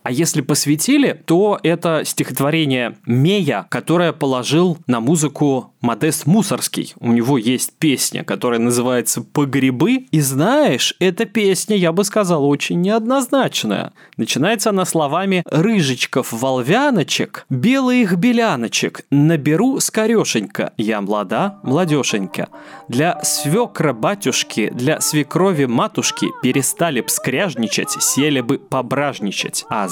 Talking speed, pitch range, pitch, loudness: 110 wpm, 130-195 Hz, 150 Hz, -17 LUFS